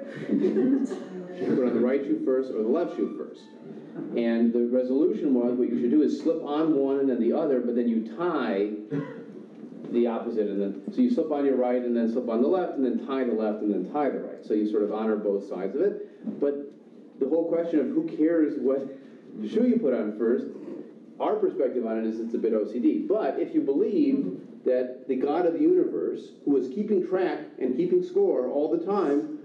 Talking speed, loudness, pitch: 225 wpm, -26 LUFS, 140 Hz